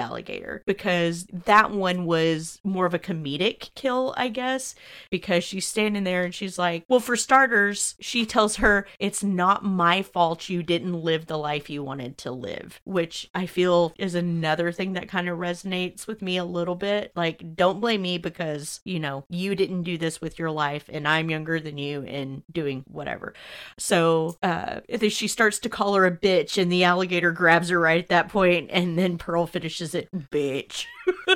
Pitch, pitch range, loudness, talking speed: 180 Hz, 165-195 Hz, -24 LUFS, 190 wpm